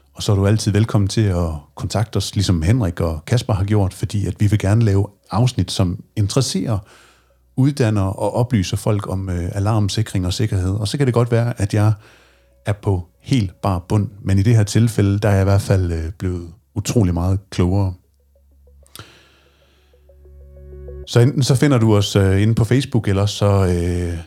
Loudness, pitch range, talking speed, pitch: -18 LUFS, 90-110 Hz, 190 wpm, 100 Hz